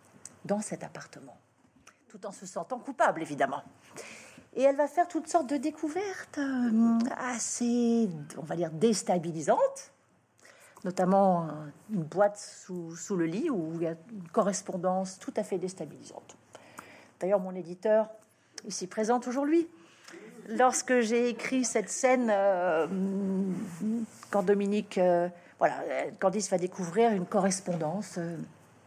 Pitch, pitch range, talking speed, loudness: 205 Hz, 180-240 Hz, 125 wpm, -30 LUFS